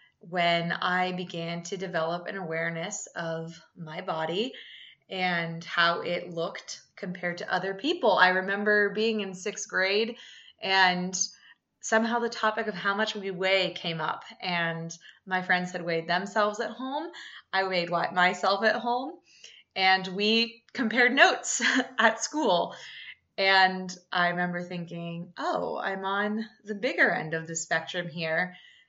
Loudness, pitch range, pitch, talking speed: -27 LUFS, 175-215 Hz, 185 Hz, 140 wpm